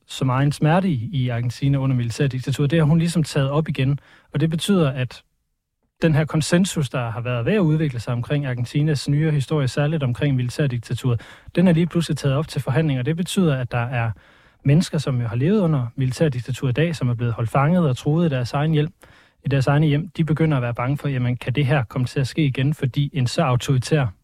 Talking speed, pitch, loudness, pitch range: 230 wpm, 145 Hz, -21 LUFS, 125-155 Hz